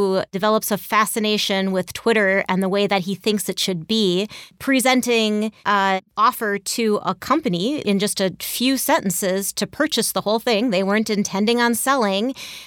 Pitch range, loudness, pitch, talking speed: 195-230 Hz, -20 LUFS, 210 Hz, 165 wpm